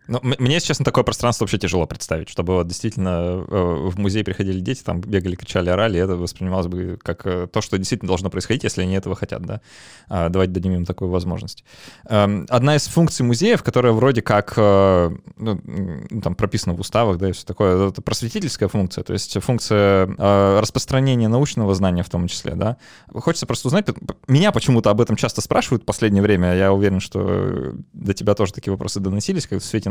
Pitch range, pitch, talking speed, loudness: 95-120 Hz, 100 Hz, 185 wpm, -20 LUFS